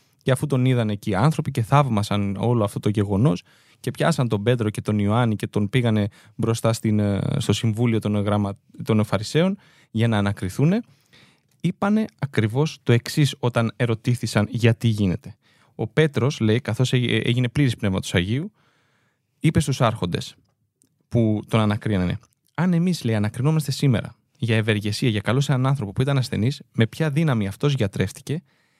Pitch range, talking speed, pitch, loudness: 105-140 Hz, 155 wpm, 120 Hz, -22 LUFS